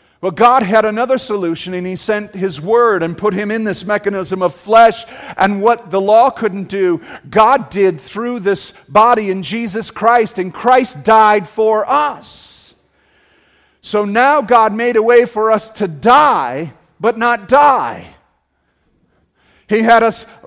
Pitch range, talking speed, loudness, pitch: 190-230 Hz, 155 wpm, -13 LUFS, 215 Hz